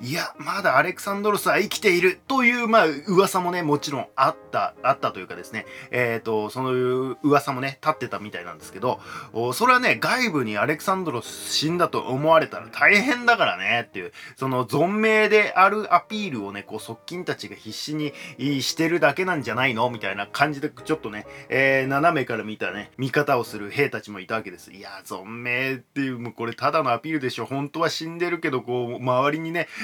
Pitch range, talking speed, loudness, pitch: 125-175 Hz, 420 characters per minute, -22 LUFS, 140 Hz